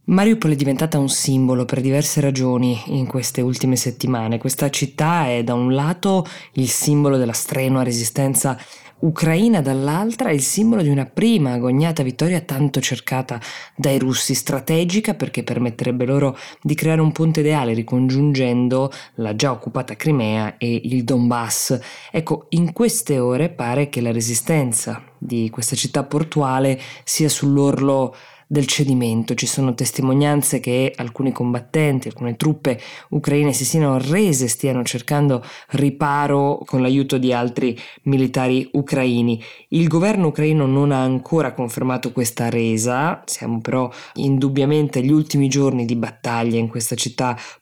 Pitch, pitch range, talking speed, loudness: 135 Hz, 125-150 Hz, 140 wpm, -19 LUFS